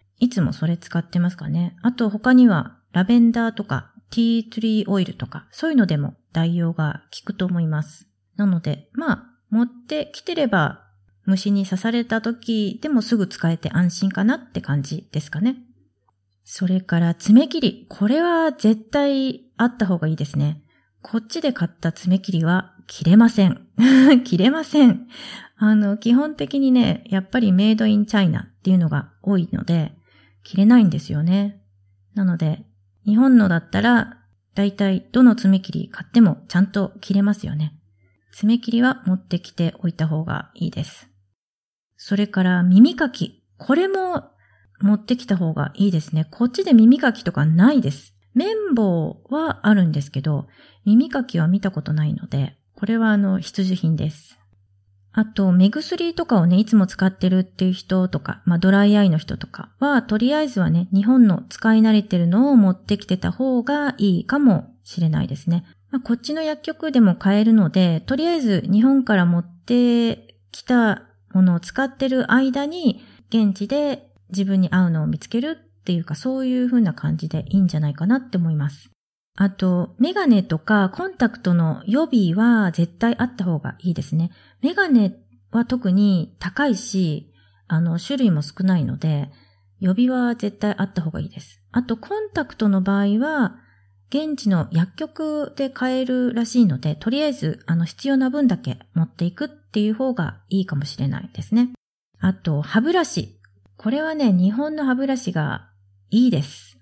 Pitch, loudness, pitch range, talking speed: 195 Hz, -20 LUFS, 165-240 Hz, 330 characters per minute